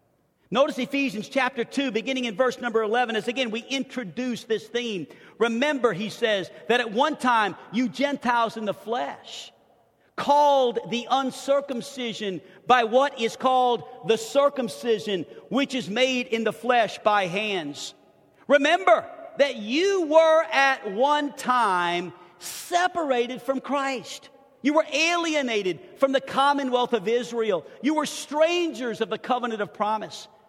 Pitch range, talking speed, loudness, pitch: 220-275 Hz, 140 wpm, -24 LUFS, 250 Hz